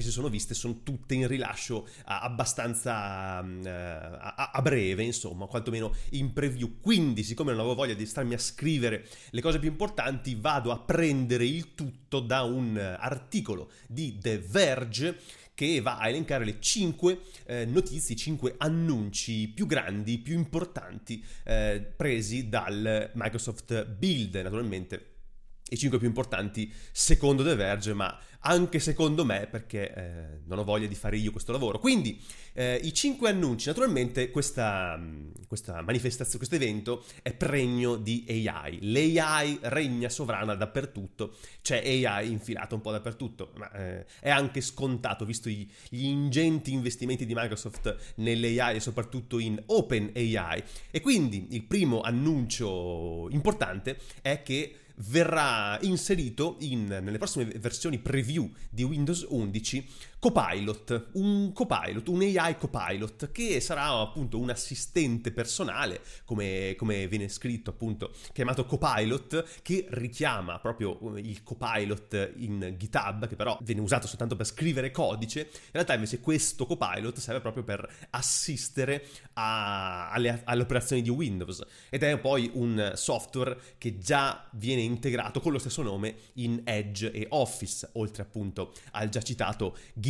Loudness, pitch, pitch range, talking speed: -30 LUFS, 120 Hz, 110-140 Hz, 140 wpm